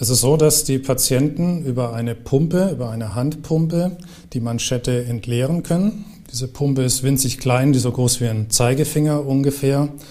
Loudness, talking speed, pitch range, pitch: -19 LUFS, 170 wpm, 125-150 Hz, 135 Hz